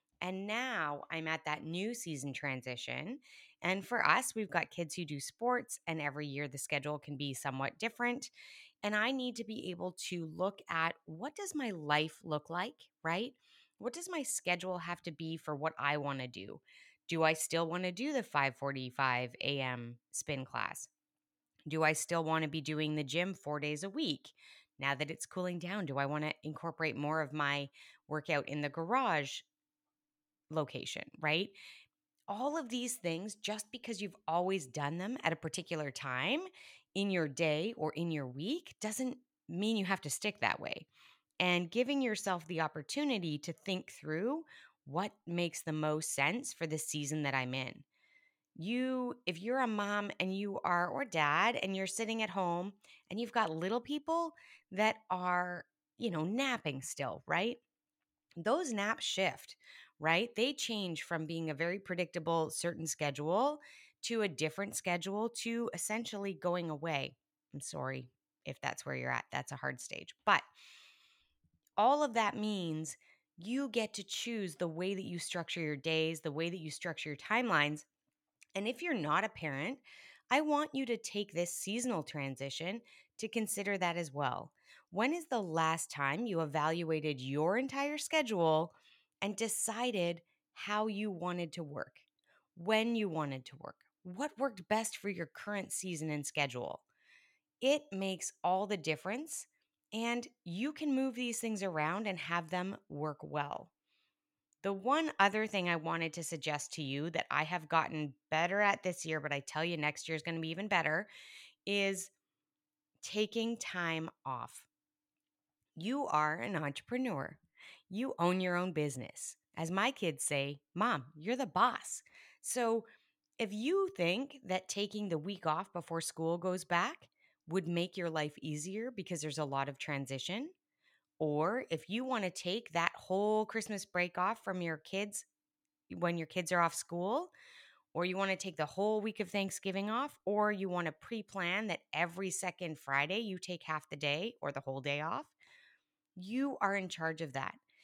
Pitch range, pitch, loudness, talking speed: 155-225 Hz, 180 Hz, -37 LUFS, 175 wpm